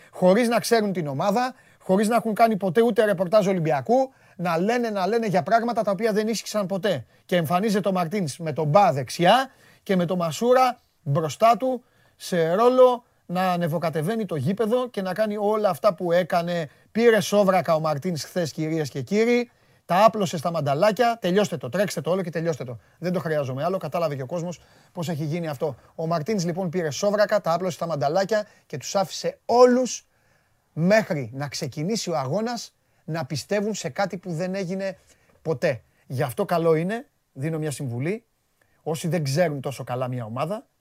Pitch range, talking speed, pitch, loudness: 160-215 Hz, 180 wpm, 180 Hz, -23 LUFS